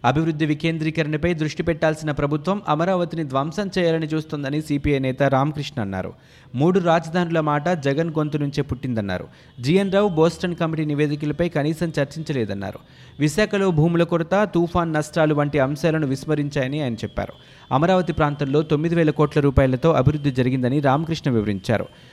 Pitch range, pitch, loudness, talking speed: 140-165 Hz, 150 Hz, -21 LUFS, 125 wpm